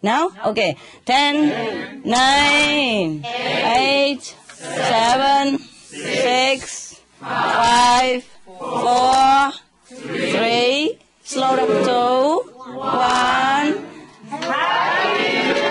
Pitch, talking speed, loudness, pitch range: 260 Hz, 55 wpm, -17 LUFS, 245-275 Hz